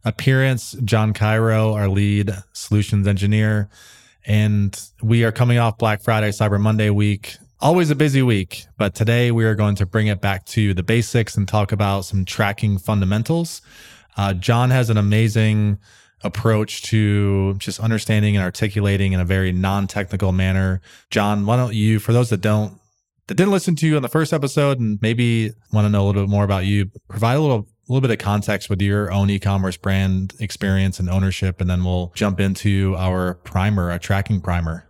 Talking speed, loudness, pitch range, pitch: 185 wpm, -19 LUFS, 100-110 Hz, 105 Hz